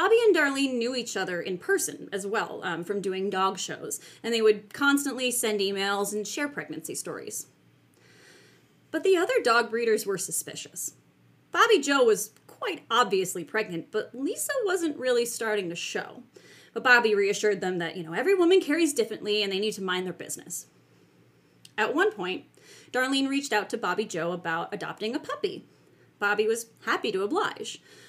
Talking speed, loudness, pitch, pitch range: 175 wpm, -27 LUFS, 220 Hz, 195-285 Hz